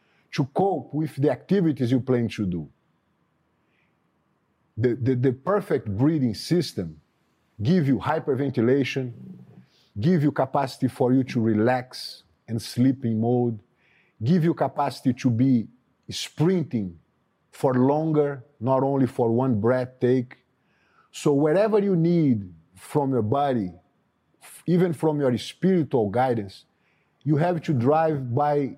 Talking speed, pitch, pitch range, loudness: 125 wpm, 130 Hz, 120-150 Hz, -24 LUFS